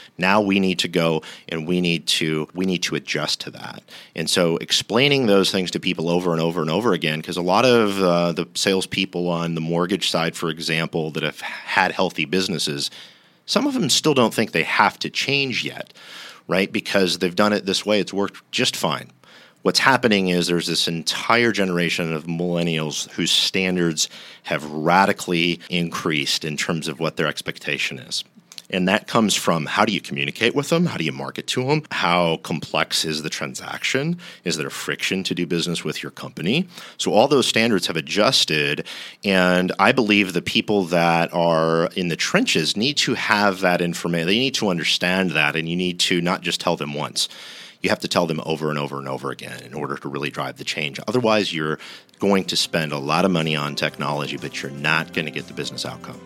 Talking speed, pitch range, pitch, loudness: 205 wpm, 80-95 Hz, 85 Hz, -21 LUFS